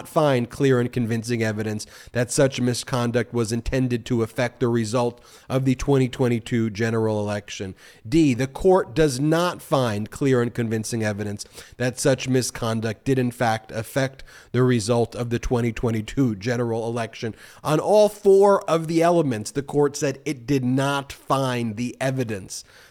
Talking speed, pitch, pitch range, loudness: 150 wpm, 125 Hz, 115-135 Hz, -23 LUFS